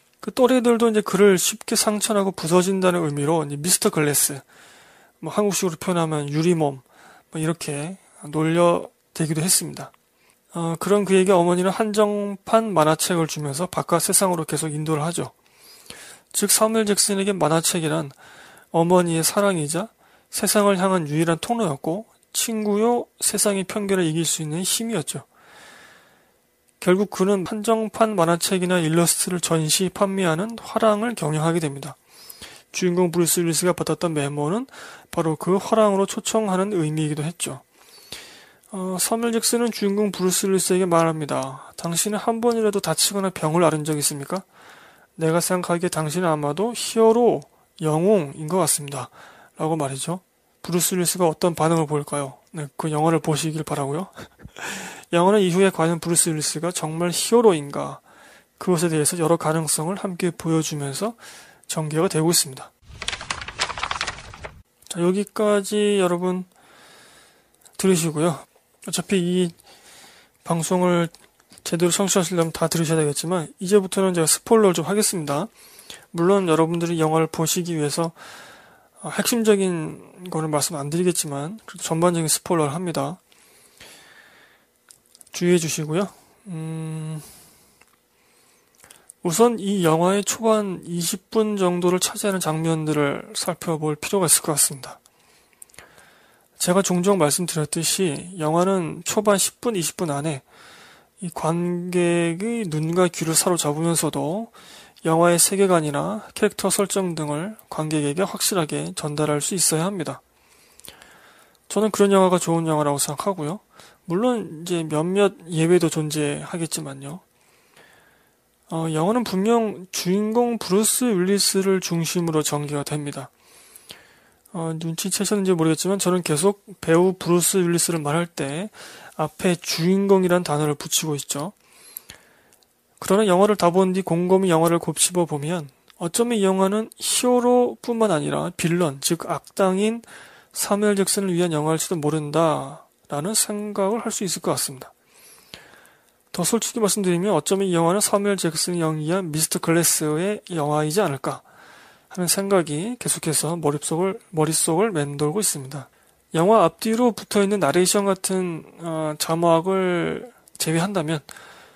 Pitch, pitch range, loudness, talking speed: 175 Hz, 160-200 Hz, -21 LUFS, 305 characters per minute